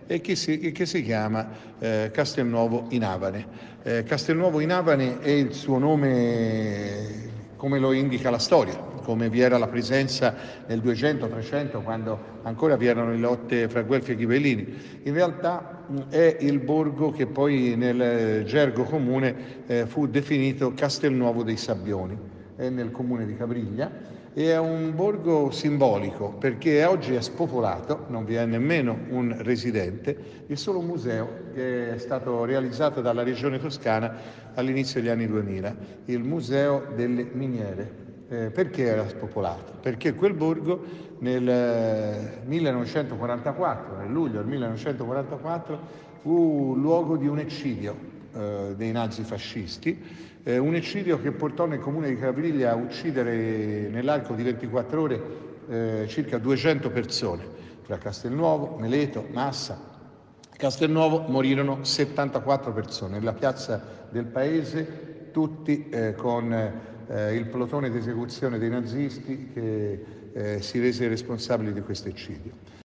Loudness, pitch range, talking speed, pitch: -26 LUFS, 115-145 Hz, 135 wpm, 125 Hz